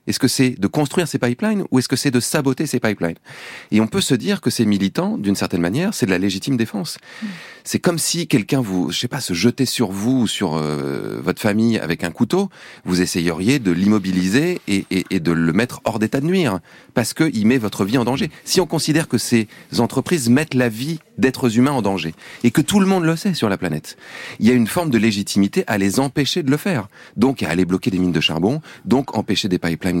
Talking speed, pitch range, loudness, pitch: 240 wpm, 95-150 Hz, -19 LUFS, 120 Hz